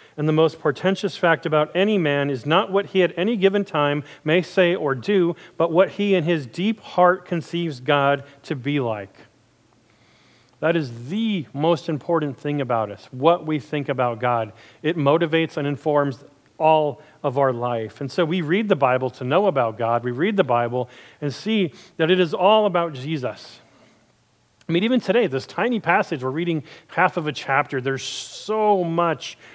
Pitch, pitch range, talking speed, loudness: 155 Hz, 135-180 Hz, 185 wpm, -21 LUFS